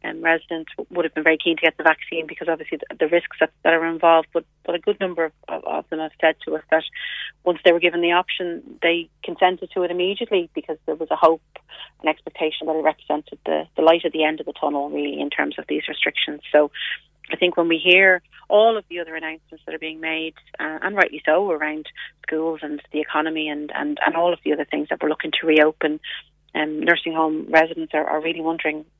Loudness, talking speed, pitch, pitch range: -21 LUFS, 240 wpm, 160 Hz, 155-170 Hz